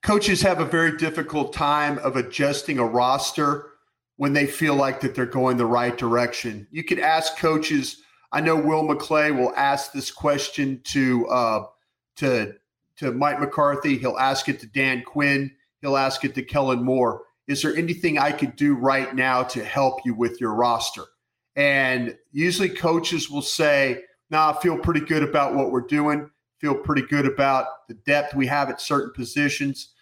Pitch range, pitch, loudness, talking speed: 130-150 Hz, 140 Hz, -22 LUFS, 180 wpm